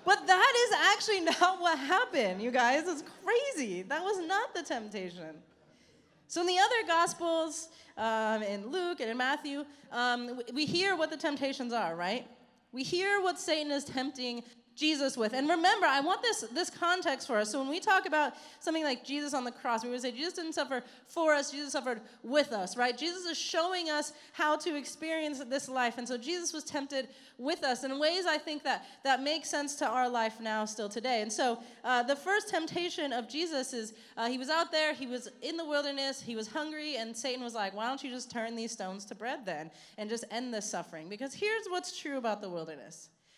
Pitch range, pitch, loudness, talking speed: 240-325 Hz, 275 Hz, -32 LUFS, 215 wpm